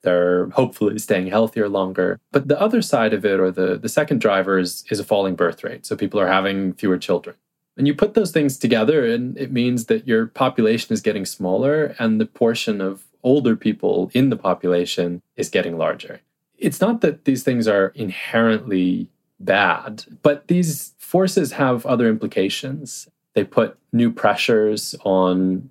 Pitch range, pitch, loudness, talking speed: 95-135 Hz, 115 Hz, -20 LUFS, 175 wpm